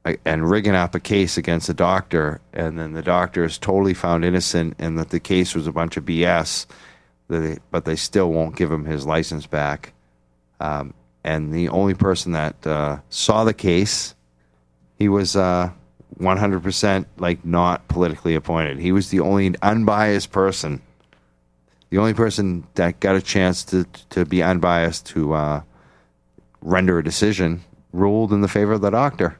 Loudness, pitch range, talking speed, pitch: -20 LUFS, 80-95 Hz, 165 wpm, 85 Hz